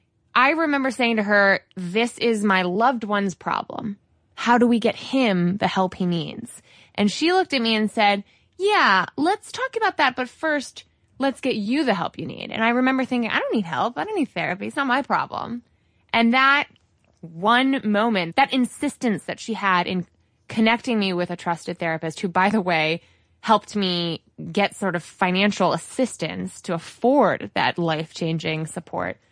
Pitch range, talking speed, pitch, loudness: 180-250 Hz, 185 wpm, 215 Hz, -22 LUFS